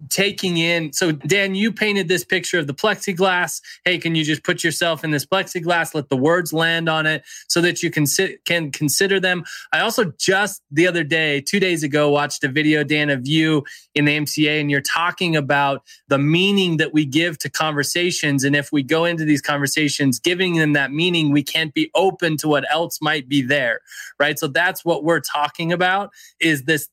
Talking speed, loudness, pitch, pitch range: 205 wpm, -19 LUFS, 160 Hz, 150-175 Hz